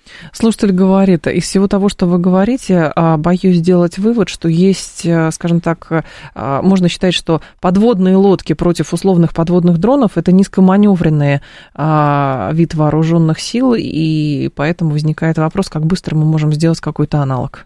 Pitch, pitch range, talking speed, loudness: 170 Hz, 155-190 Hz, 135 wpm, -13 LUFS